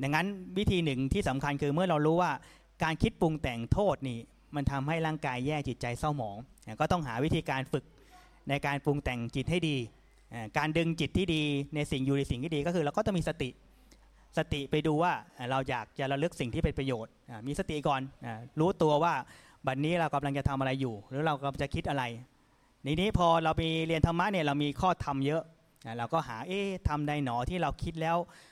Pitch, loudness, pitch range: 145 Hz, -32 LUFS, 135-165 Hz